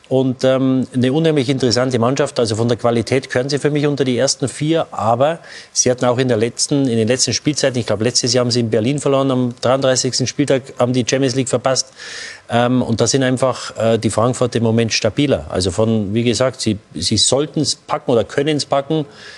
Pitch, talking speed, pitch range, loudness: 125 Hz, 215 wpm, 120-135 Hz, -16 LUFS